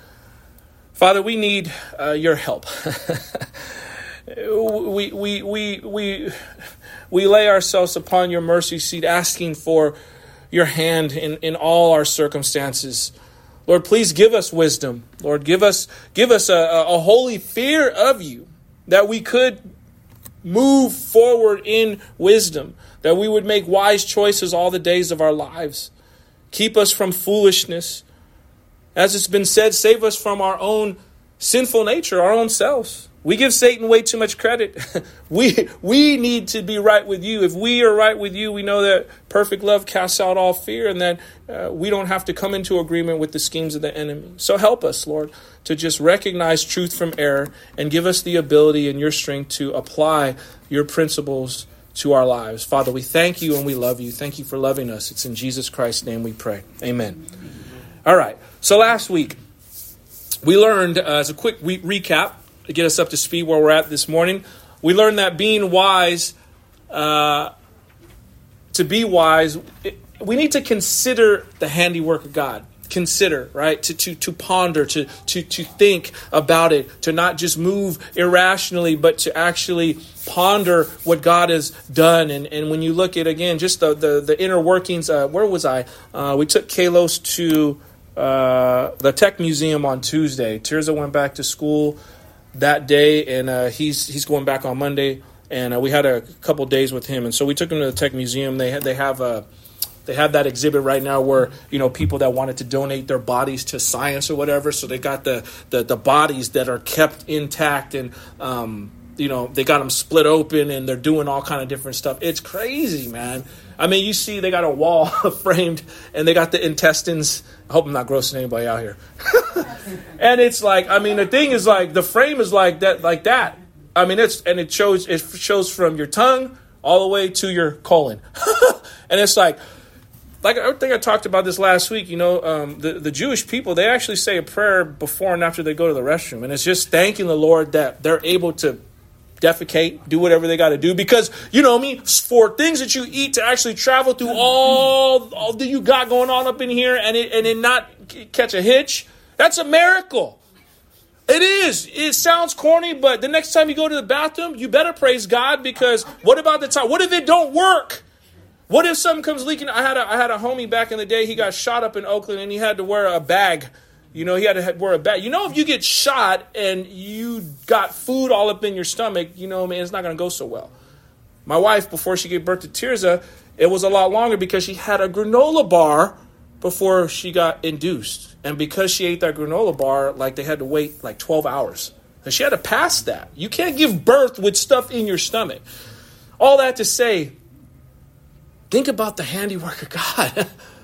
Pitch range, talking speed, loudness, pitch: 150-215 Hz, 205 wpm, -17 LUFS, 175 Hz